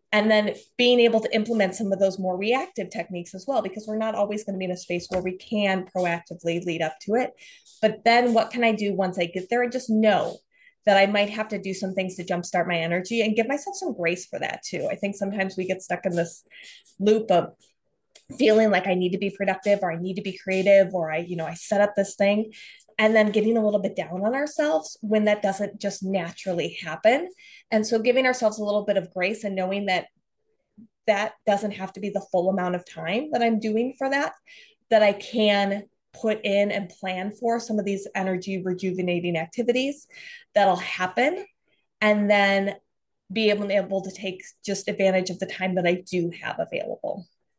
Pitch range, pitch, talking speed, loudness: 185-220 Hz, 200 Hz, 220 wpm, -24 LUFS